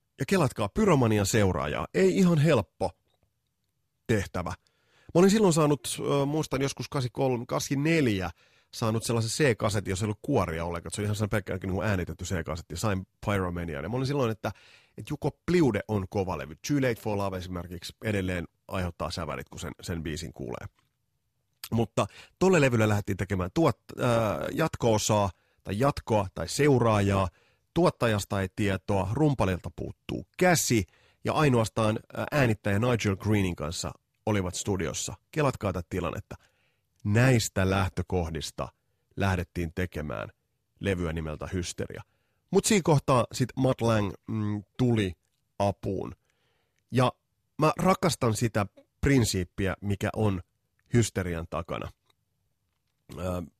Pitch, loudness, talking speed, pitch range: 105 Hz, -28 LUFS, 125 wpm, 95-125 Hz